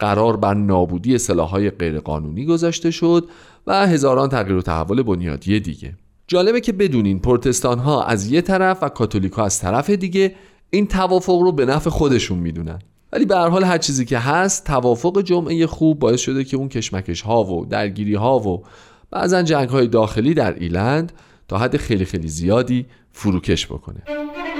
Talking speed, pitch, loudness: 170 wpm, 125 Hz, -18 LUFS